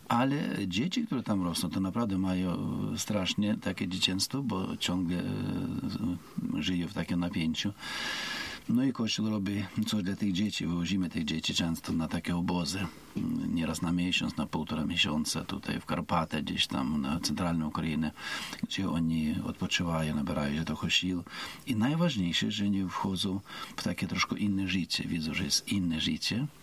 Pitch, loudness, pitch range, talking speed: 90 Hz, -31 LUFS, 85-95 Hz, 155 wpm